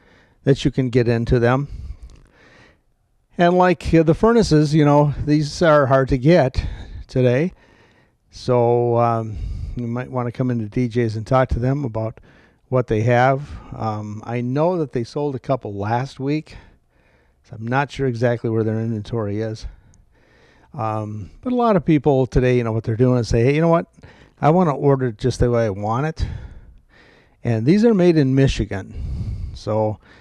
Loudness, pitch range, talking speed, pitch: -19 LUFS, 110-140 Hz, 180 wpm, 125 Hz